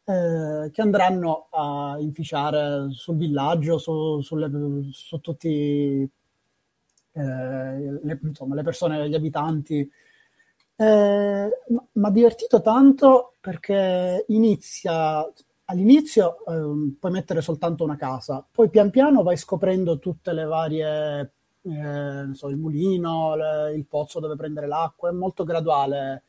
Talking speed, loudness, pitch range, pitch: 125 wpm, -22 LUFS, 145-190 Hz, 160 Hz